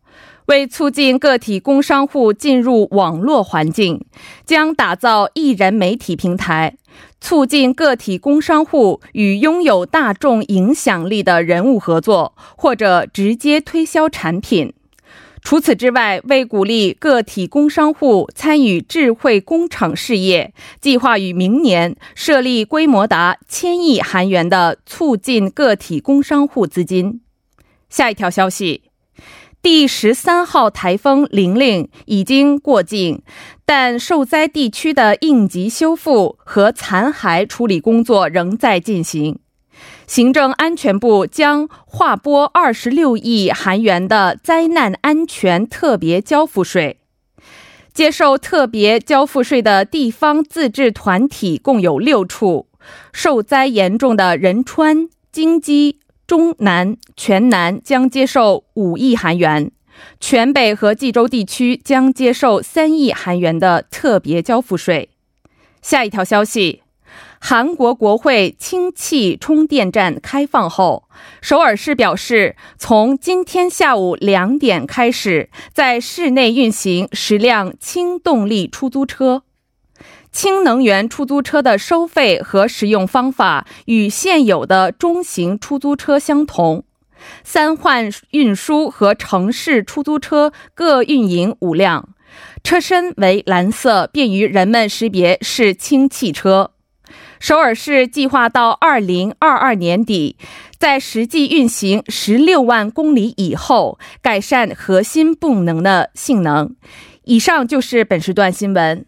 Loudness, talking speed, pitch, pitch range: -14 LUFS, 195 characters per minute, 245 Hz, 200-290 Hz